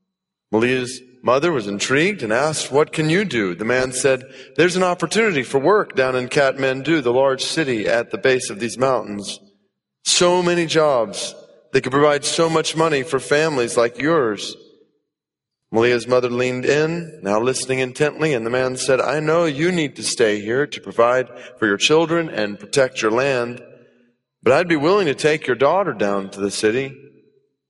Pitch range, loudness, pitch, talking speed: 120-155 Hz, -19 LUFS, 130 Hz, 180 wpm